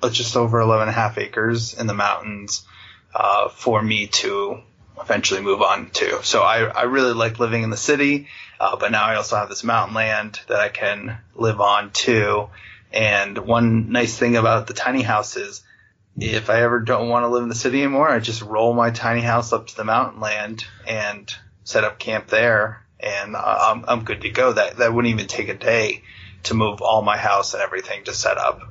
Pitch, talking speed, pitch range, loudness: 110 Hz, 215 wpm, 105-120 Hz, -20 LUFS